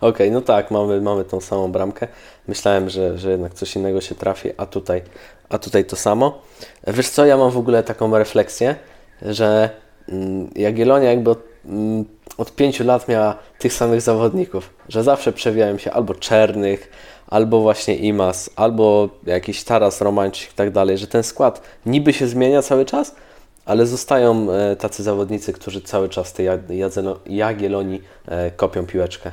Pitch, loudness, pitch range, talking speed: 105 Hz, -18 LUFS, 95-115 Hz, 160 wpm